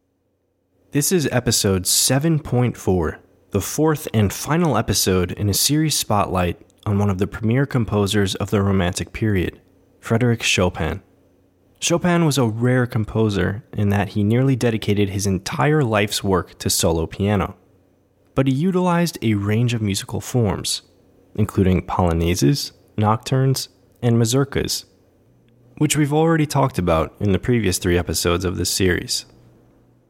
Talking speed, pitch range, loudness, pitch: 135 wpm, 95-125 Hz, -20 LUFS, 105 Hz